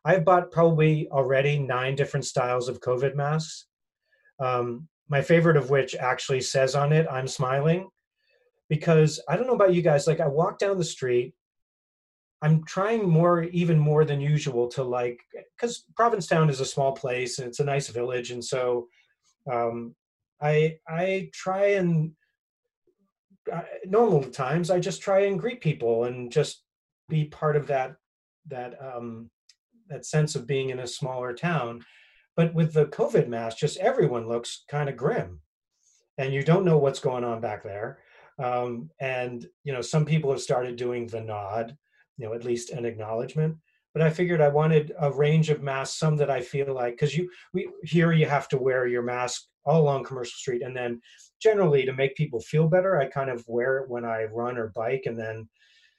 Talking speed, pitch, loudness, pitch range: 185 wpm, 140 Hz, -26 LUFS, 125-165 Hz